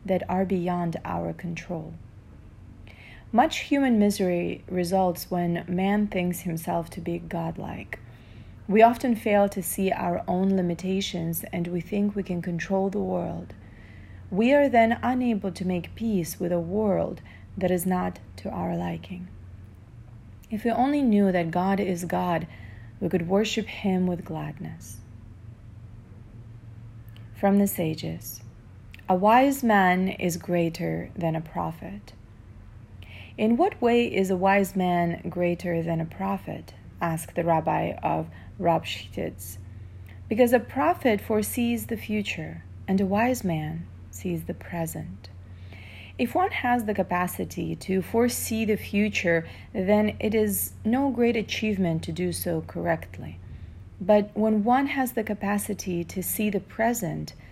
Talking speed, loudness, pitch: 135 wpm, -26 LUFS, 175 Hz